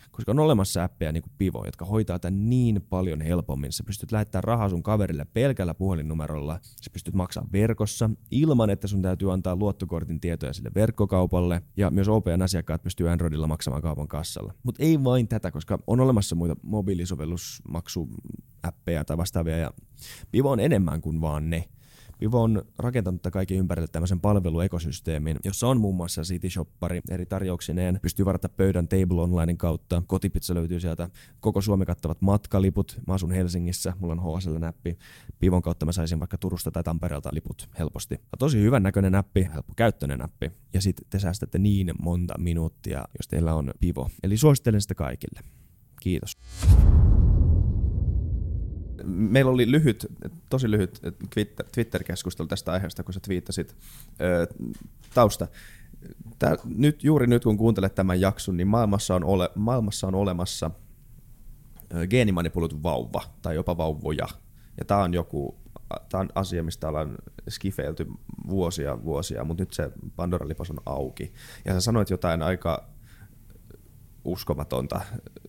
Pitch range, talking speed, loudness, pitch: 85-105 Hz, 145 wpm, -26 LUFS, 90 Hz